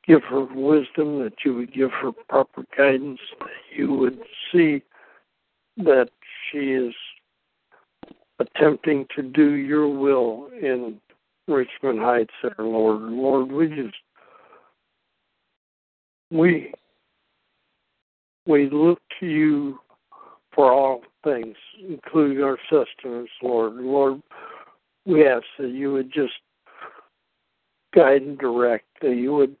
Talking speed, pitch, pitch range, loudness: 115 wpm, 140 Hz, 125-150 Hz, -21 LUFS